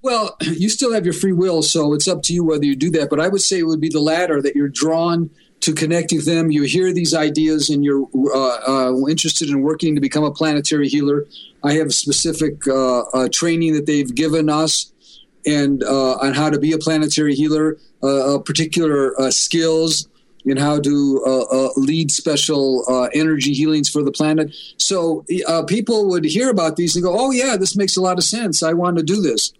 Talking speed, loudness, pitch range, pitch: 220 wpm, -17 LUFS, 145-165 Hz, 155 Hz